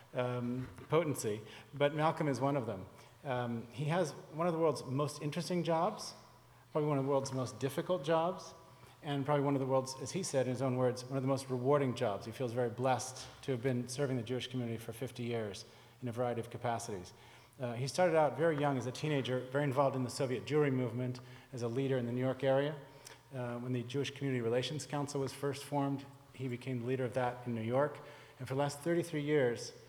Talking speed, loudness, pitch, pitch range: 225 wpm, -36 LUFS, 130 Hz, 125-145 Hz